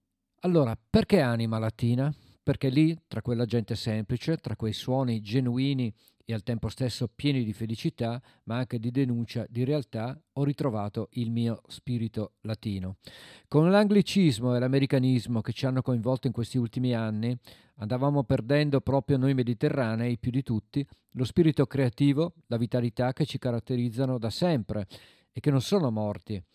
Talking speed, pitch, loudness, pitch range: 155 wpm, 125 Hz, -28 LUFS, 115-140 Hz